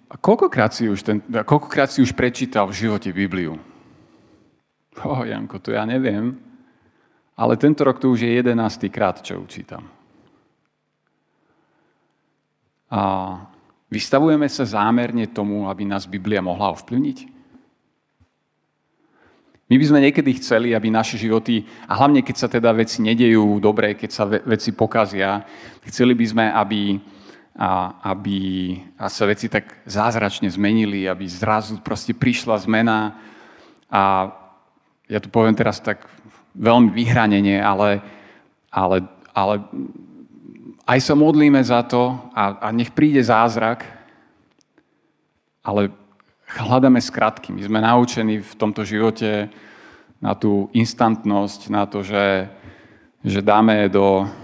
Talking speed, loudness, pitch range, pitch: 125 wpm, -19 LUFS, 100-120 Hz, 110 Hz